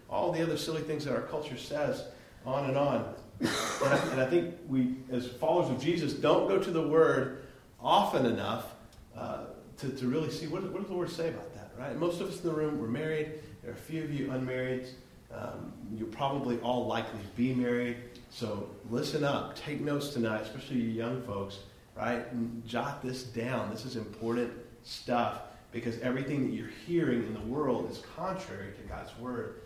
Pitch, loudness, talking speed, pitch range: 130 Hz, -33 LUFS, 200 wpm, 120-155 Hz